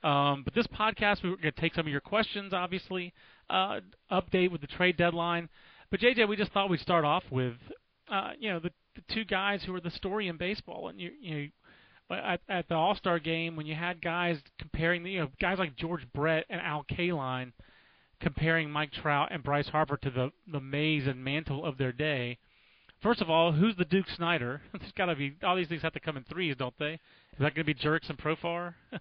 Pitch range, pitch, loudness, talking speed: 150-185 Hz, 170 Hz, -31 LUFS, 230 wpm